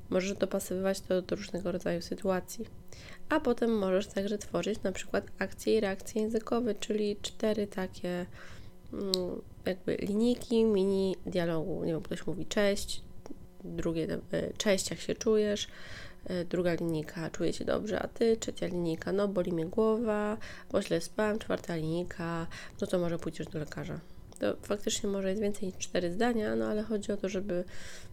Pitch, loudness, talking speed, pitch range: 190 Hz, -33 LUFS, 165 wpm, 170-210 Hz